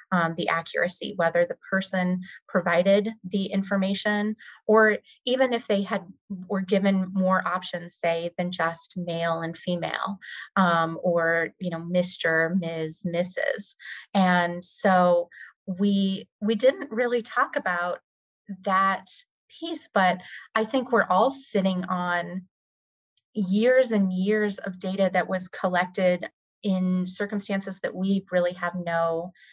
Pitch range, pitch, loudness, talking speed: 175-200 Hz, 185 Hz, -25 LUFS, 130 wpm